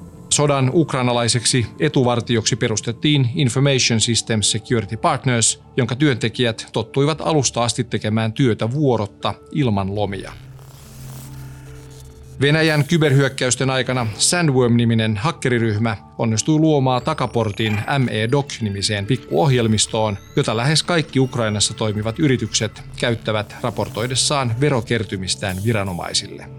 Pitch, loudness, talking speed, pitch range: 120 Hz, -19 LUFS, 85 wpm, 110-135 Hz